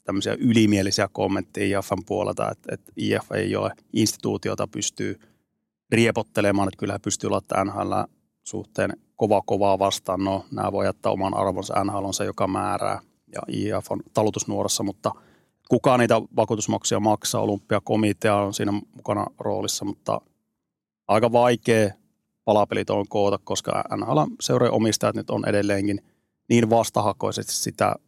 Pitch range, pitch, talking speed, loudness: 100-110 Hz, 105 Hz, 135 wpm, -24 LUFS